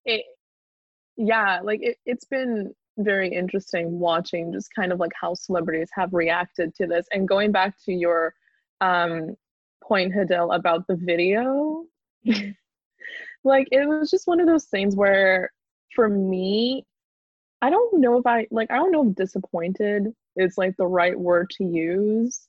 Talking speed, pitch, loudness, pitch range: 155 wpm, 200 Hz, -23 LUFS, 180-245 Hz